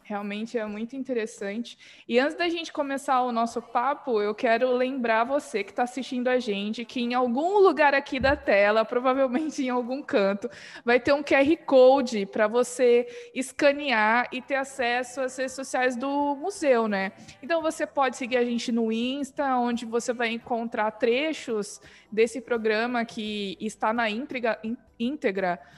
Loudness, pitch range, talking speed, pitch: -25 LUFS, 225-270 Hz, 160 wpm, 245 Hz